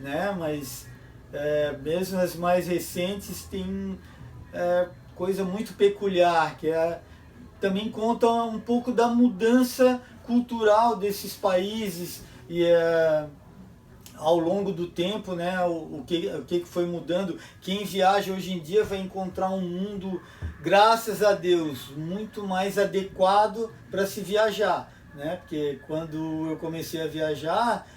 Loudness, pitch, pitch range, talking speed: -26 LUFS, 185 Hz, 160-205 Hz, 135 wpm